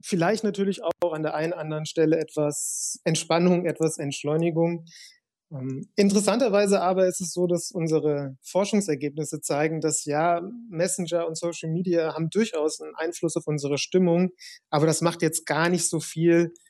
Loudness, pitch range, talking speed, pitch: -25 LUFS, 155-180 Hz, 155 wpm, 165 Hz